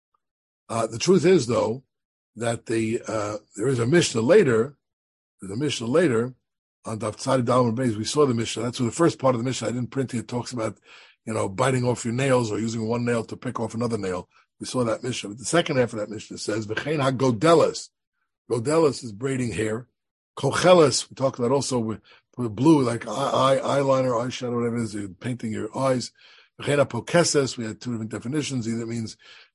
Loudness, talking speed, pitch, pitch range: -24 LUFS, 205 wpm, 120 Hz, 110-130 Hz